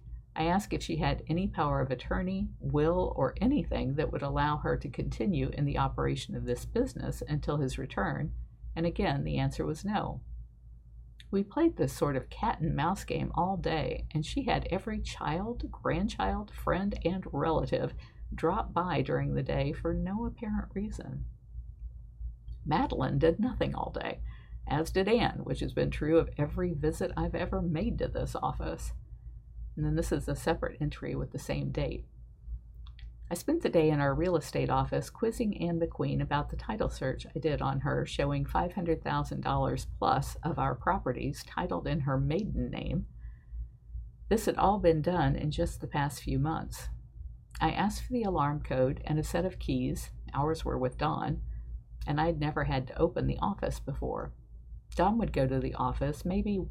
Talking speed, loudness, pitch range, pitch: 175 wpm, -32 LUFS, 125-170 Hz, 150 Hz